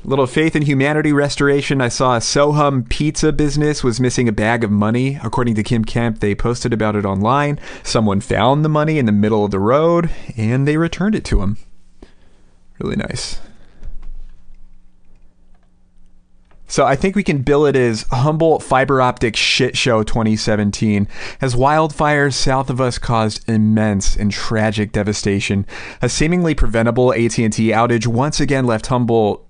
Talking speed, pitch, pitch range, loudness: 160 wpm, 120 Hz, 110-145 Hz, -16 LUFS